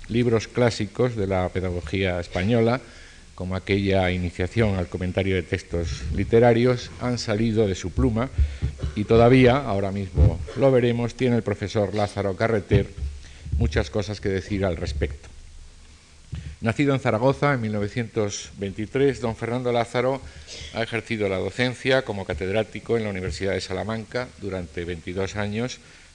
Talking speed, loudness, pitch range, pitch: 135 wpm, -24 LUFS, 90-115 Hz, 100 Hz